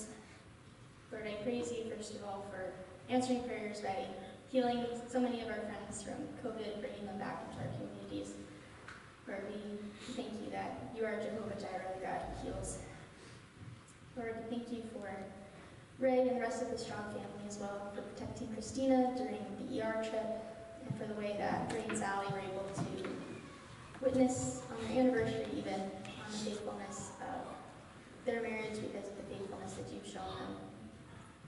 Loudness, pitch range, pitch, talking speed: -40 LUFS, 195-240 Hz, 220 Hz, 175 wpm